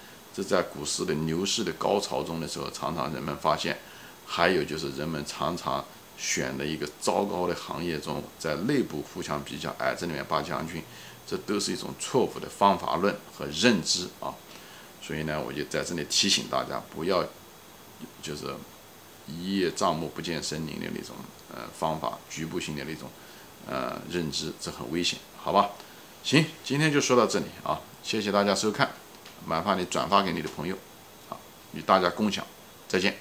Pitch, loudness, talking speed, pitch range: 85 Hz, -29 LUFS, 260 characters per minute, 75-100 Hz